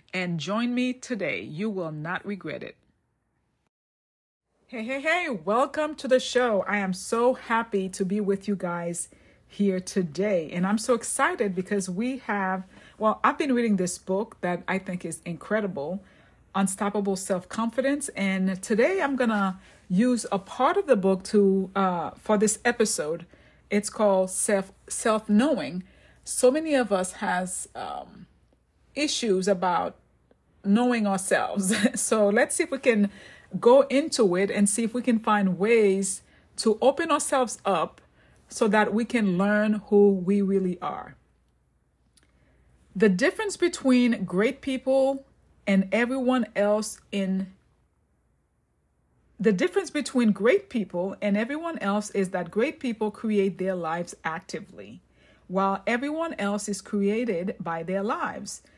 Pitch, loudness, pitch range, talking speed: 205 Hz, -25 LUFS, 190-240 Hz, 140 wpm